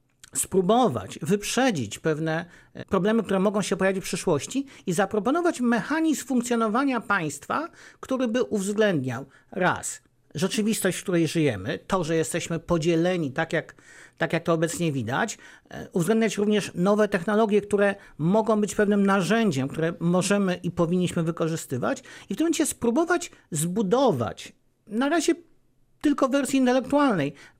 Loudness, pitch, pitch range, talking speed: -25 LUFS, 200 Hz, 170-235 Hz, 130 wpm